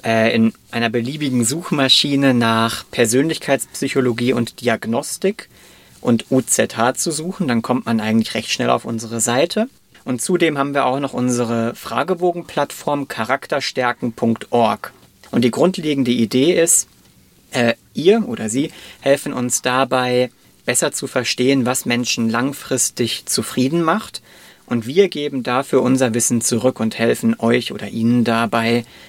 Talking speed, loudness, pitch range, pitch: 130 wpm, -18 LUFS, 115-140 Hz, 125 Hz